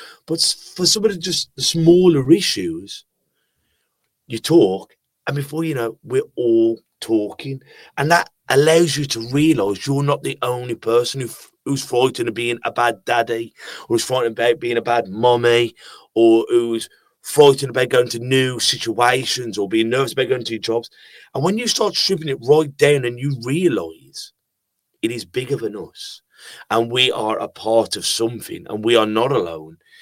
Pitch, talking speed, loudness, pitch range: 125 Hz, 175 wpm, -18 LUFS, 115-155 Hz